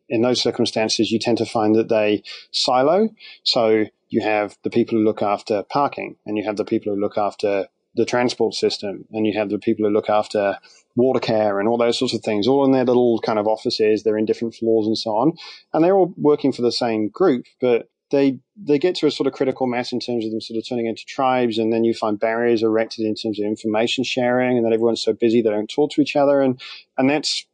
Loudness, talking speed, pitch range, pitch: -20 LUFS, 245 wpm, 110-130 Hz, 115 Hz